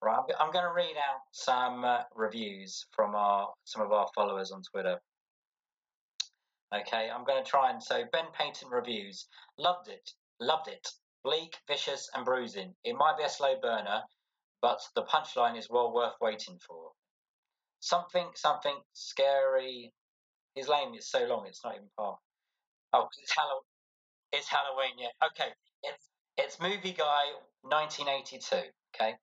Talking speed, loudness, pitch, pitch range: 150 wpm, -32 LUFS, 145 Hz, 120-185 Hz